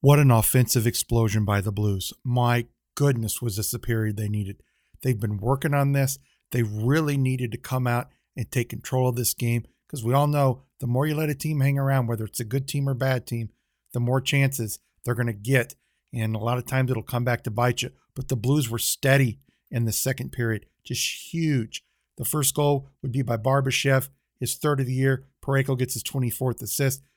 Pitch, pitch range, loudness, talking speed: 125 Hz, 115-135 Hz, -25 LUFS, 215 wpm